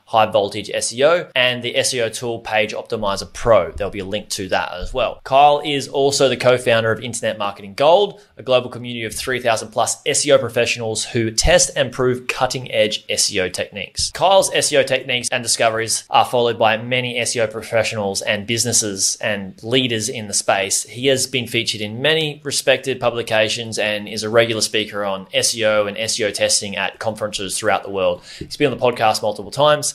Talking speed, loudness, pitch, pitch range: 185 wpm, -18 LUFS, 115 Hz, 105-130 Hz